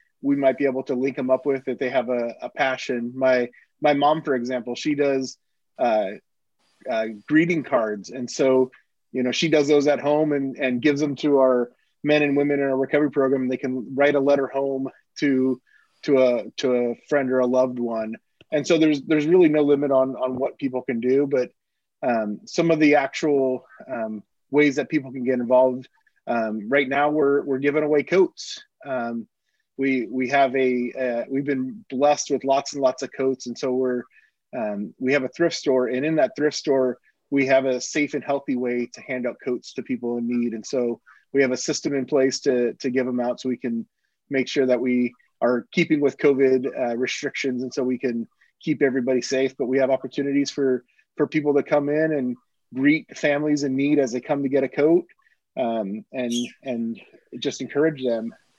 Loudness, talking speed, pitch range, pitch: -23 LUFS, 210 wpm, 125-145 Hz, 135 Hz